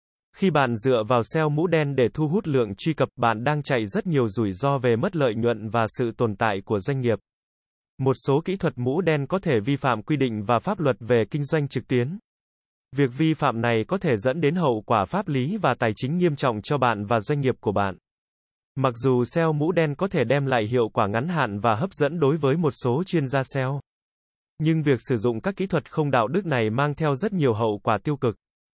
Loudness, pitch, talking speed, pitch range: -24 LUFS, 135 Hz, 245 wpm, 120-155 Hz